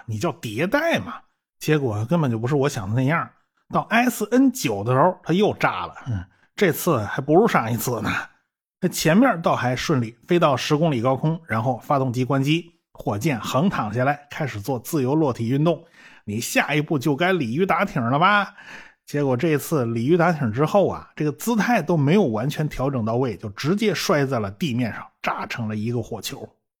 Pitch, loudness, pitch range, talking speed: 145 Hz, -22 LUFS, 120-170 Hz, 285 characters per minute